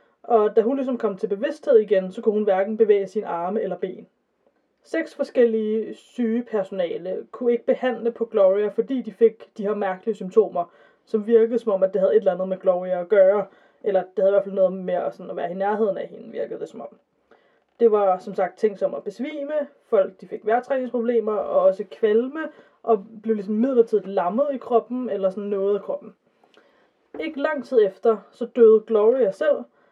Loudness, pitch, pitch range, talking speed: -22 LUFS, 220 Hz, 195-245 Hz, 205 wpm